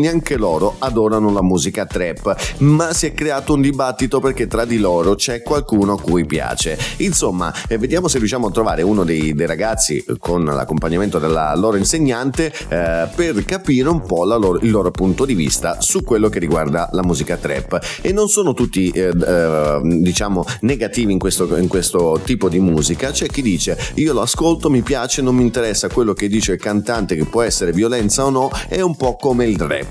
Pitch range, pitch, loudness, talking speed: 90-135 Hz, 105 Hz, -16 LUFS, 200 wpm